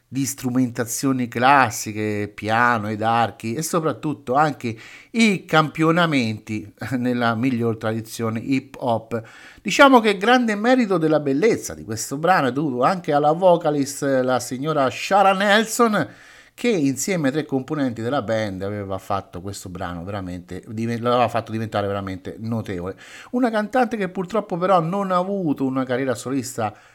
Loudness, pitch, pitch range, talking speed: -21 LUFS, 130 Hz, 110-170 Hz, 140 wpm